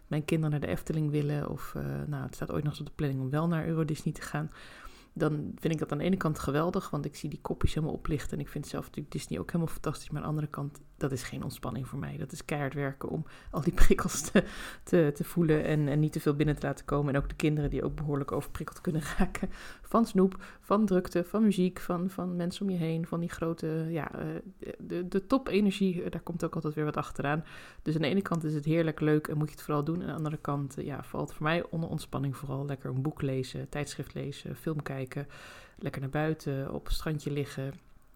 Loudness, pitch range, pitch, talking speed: -32 LUFS, 145-170 Hz, 155 Hz, 250 wpm